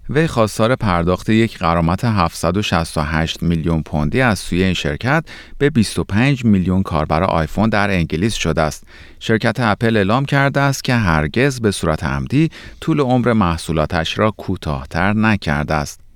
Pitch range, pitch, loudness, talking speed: 80-115 Hz, 95 Hz, -17 LUFS, 140 wpm